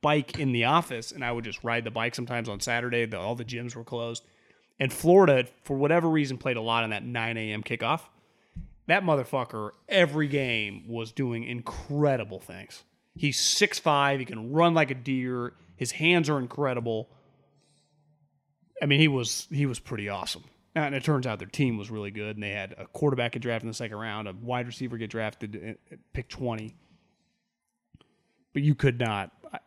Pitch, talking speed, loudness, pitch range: 125 Hz, 190 wpm, -27 LUFS, 115-145 Hz